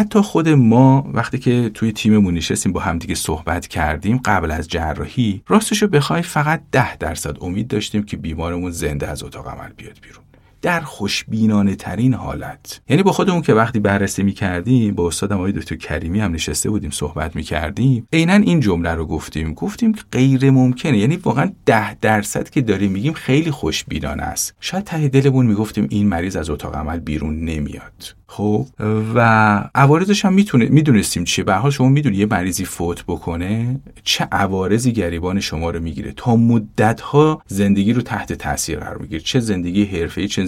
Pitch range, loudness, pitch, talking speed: 85-130 Hz, -17 LUFS, 105 Hz, 170 wpm